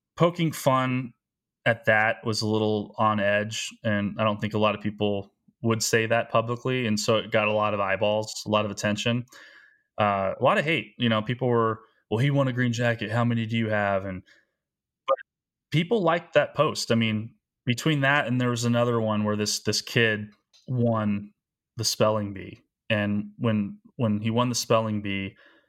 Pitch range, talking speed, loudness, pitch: 105-120 Hz, 195 wpm, -25 LUFS, 110 Hz